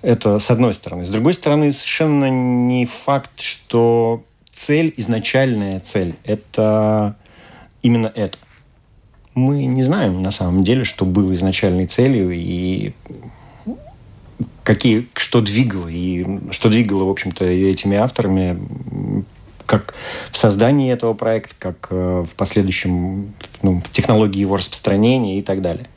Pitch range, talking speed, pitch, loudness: 95-120 Hz, 120 wpm, 105 Hz, -17 LUFS